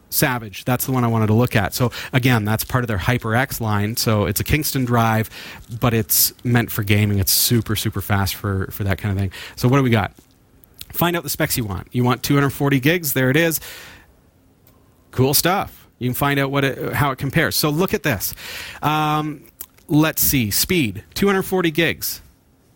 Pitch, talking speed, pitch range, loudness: 125 Hz, 200 wpm, 105-140 Hz, -19 LUFS